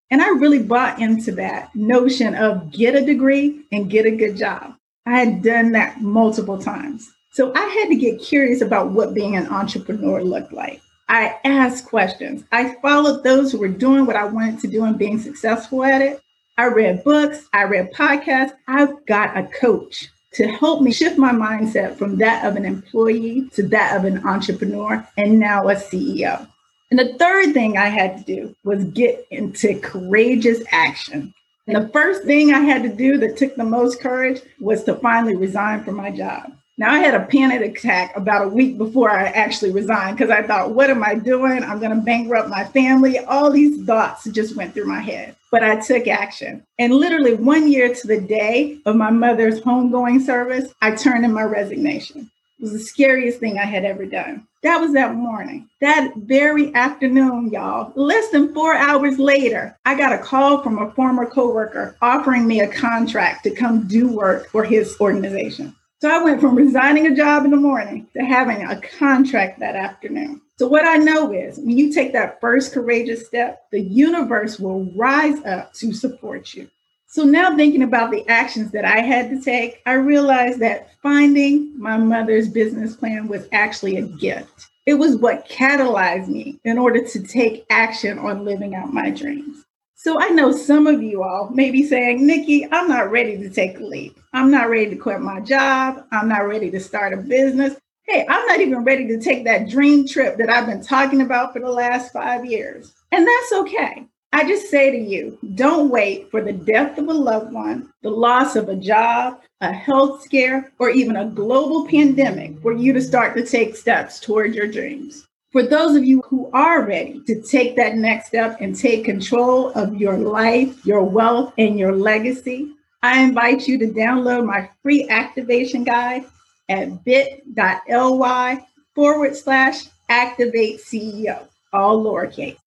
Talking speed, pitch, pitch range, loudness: 190 wpm, 245 Hz, 220-275 Hz, -17 LUFS